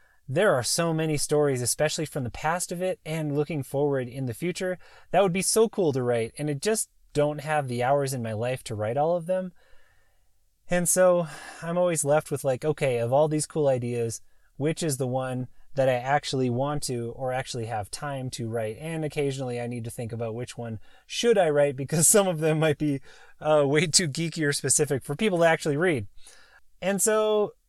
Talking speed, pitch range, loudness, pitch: 210 wpm, 125-165 Hz, -26 LUFS, 145 Hz